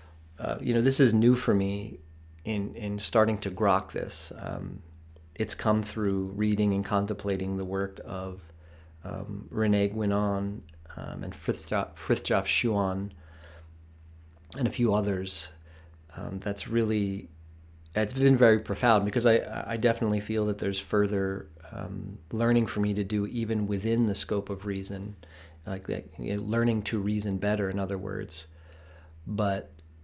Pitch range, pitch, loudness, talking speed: 85-105 Hz, 100 Hz, -29 LUFS, 150 wpm